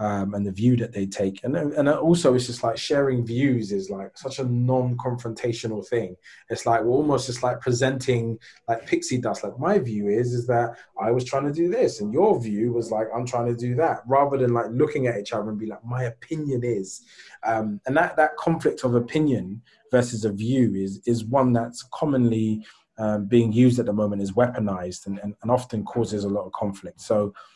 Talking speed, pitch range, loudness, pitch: 215 wpm, 110-130 Hz, -24 LUFS, 120 Hz